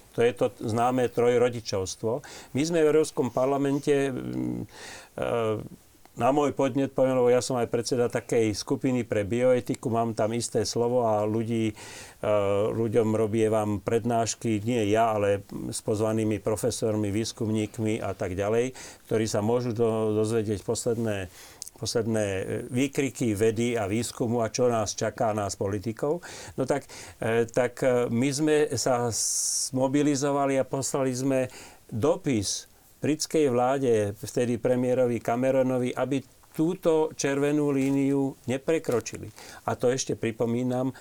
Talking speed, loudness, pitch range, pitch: 125 wpm, -26 LUFS, 110-135 Hz, 120 Hz